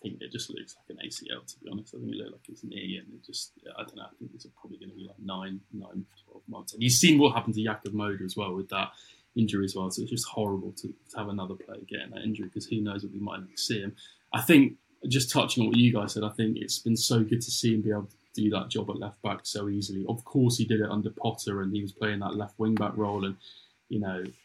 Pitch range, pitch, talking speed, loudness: 100-115 Hz, 105 Hz, 295 wpm, -29 LUFS